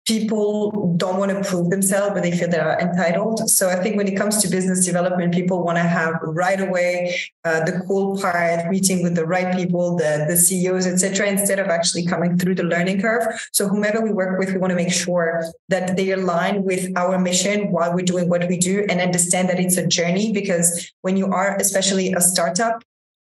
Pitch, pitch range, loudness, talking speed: 185 Hz, 175-195 Hz, -19 LUFS, 215 wpm